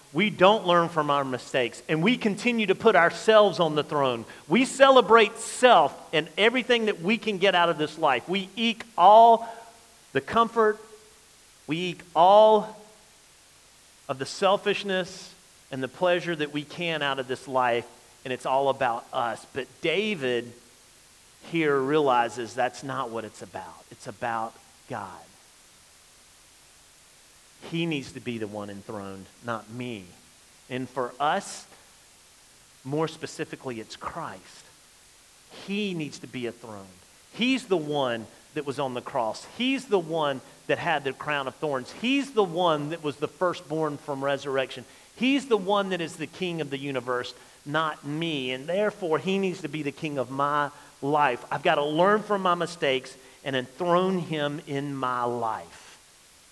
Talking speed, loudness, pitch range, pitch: 160 wpm, -25 LUFS, 125-190 Hz, 150 Hz